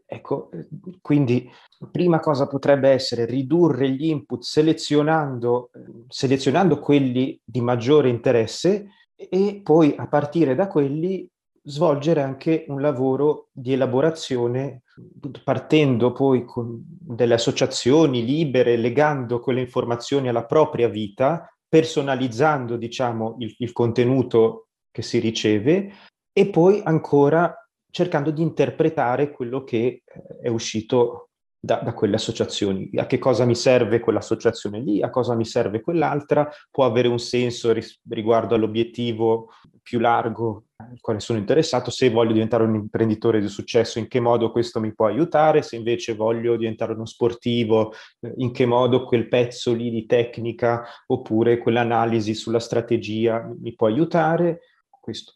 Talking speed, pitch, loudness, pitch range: 135 wpm, 125 Hz, -21 LUFS, 115-150 Hz